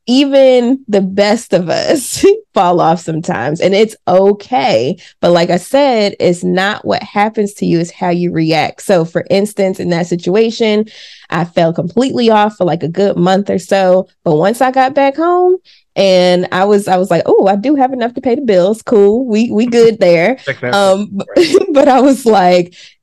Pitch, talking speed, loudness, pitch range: 200 Hz, 190 wpm, -11 LUFS, 180-235 Hz